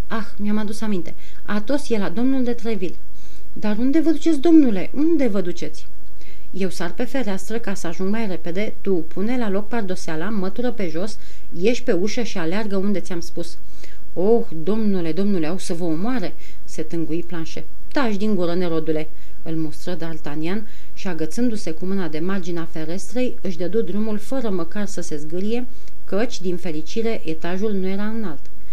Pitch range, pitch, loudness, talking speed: 170-225 Hz, 195 Hz, -24 LUFS, 170 wpm